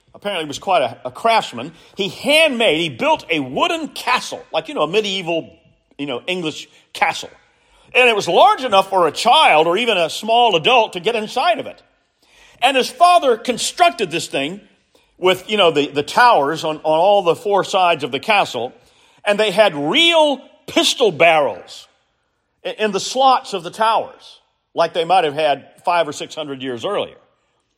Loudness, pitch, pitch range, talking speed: -16 LUFS, 205 Hz, 165-250 Hz, 185 wpm